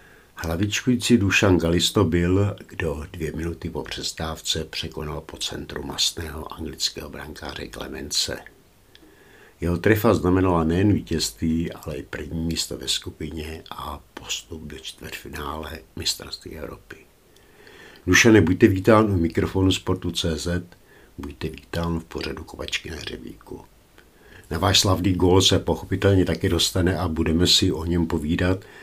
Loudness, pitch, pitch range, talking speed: -22 LUFS, 85 Hz, 80-95 Hz, 125 wpm